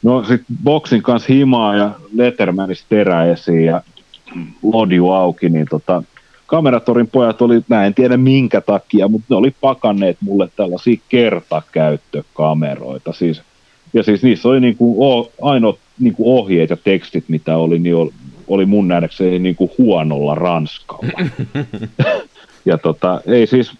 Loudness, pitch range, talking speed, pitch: -14 LUFS, 85-125 Hz, 135 wpm, 105 Hz